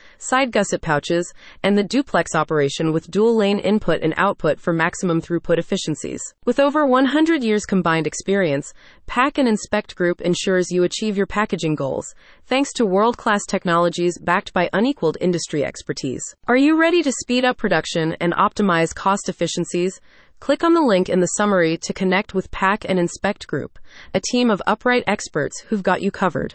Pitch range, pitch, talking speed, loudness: 170-220 Hz, 195 Hz, 175 wpm, -20 LUFS